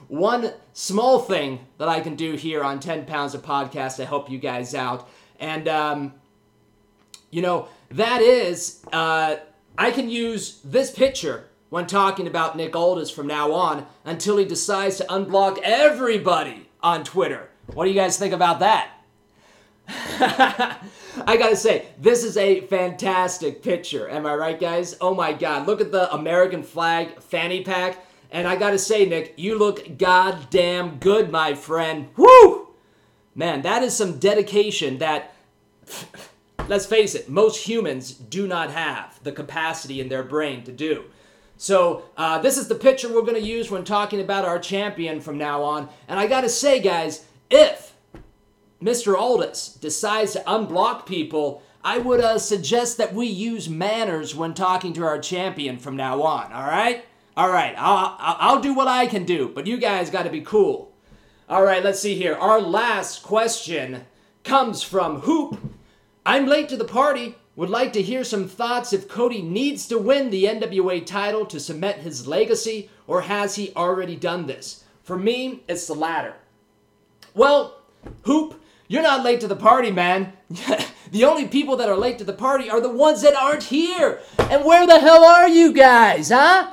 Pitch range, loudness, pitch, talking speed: 160-230 Hz, -20 LUFS, 190 Hz, 170 wpm